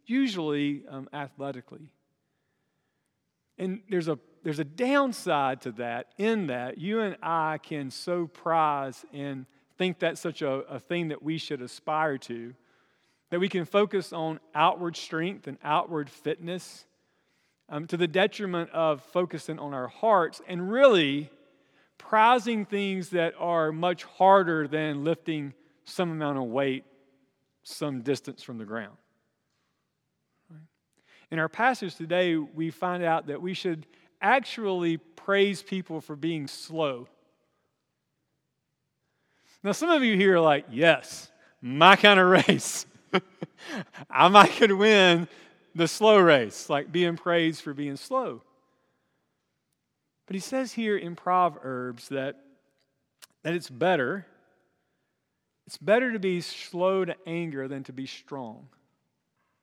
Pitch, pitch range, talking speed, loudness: 165 Hz, 145-185 Hz, 130 wpm, -26 LUFS